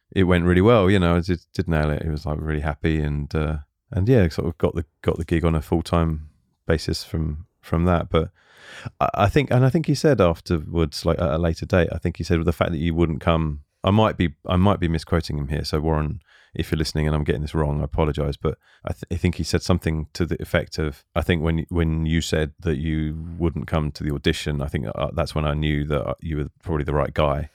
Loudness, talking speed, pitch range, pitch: -23 LUFS, 265 wpm, 75-85 Hz, 80 Hz